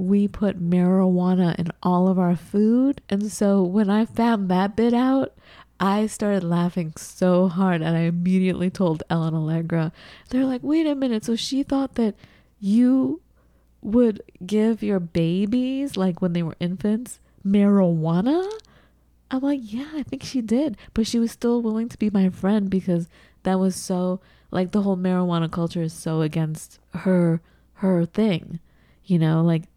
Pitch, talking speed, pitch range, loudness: 190 Hz, 165 wpm, 175-230 Hz, -22 LUFS